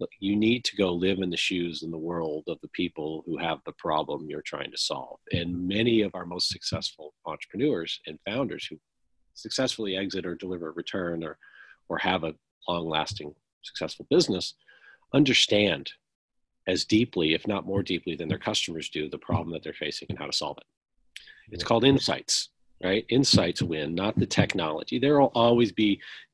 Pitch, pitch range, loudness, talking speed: 95 Hz, 85-110 Hz, -27 LUFS, 180 wpm